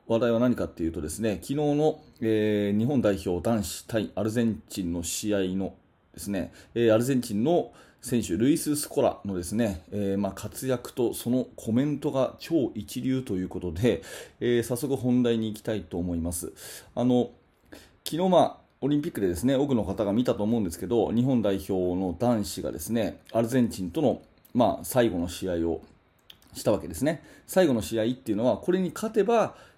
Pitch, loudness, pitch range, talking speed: 110 Hz, -27 LUFS, 95-125 Hz, 365 characters per minute